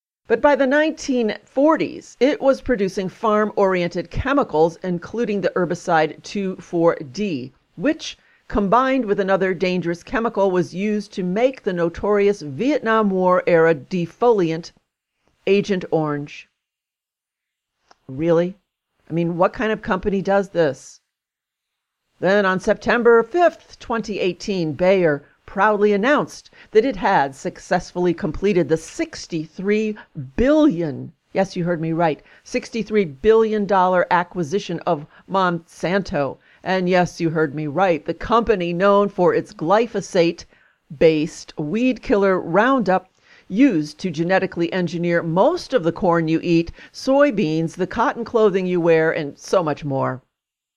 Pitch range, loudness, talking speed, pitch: 170-215 Hz, -20 LUFS, 125 wpm, 185 Hz